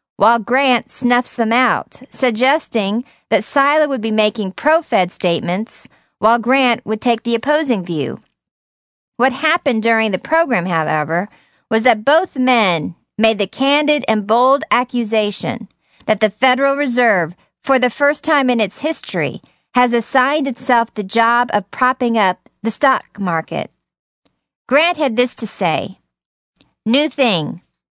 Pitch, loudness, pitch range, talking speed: 235 Hz, -16 LUFS, 215-270 Hz, 140 wpm